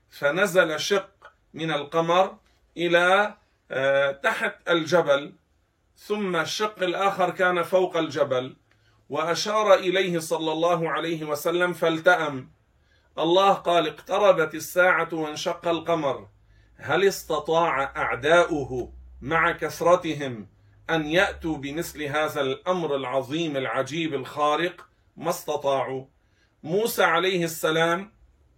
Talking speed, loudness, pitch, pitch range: 90 wpm, -24 LUFS, 160 Hz, 140-180 Hz